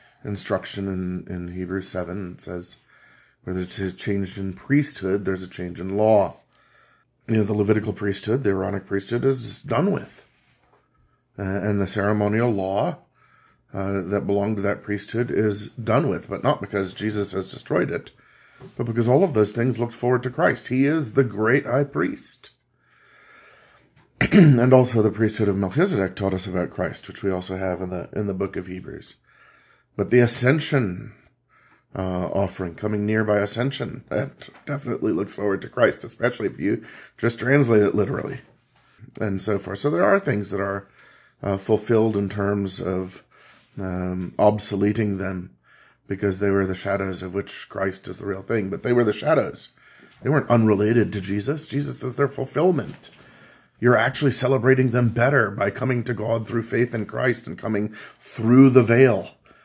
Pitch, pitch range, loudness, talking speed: 105 Hz, 95-125 Hz, -23 LUFS, 170 wpm